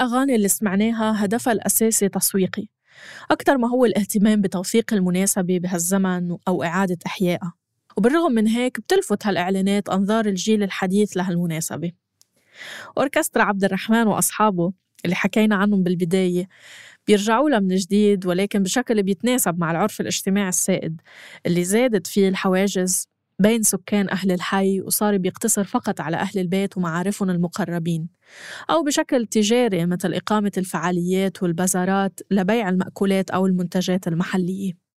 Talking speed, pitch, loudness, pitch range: 125 wpm, 195 Hz, -21 LUFS, 180-215 Hz